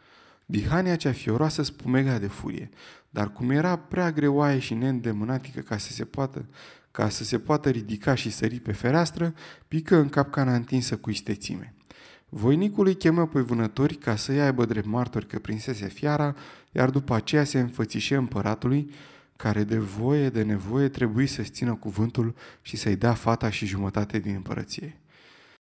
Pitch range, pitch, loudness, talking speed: 110-140 Hz, 125 Hz, -26 LUFS, 160 wpm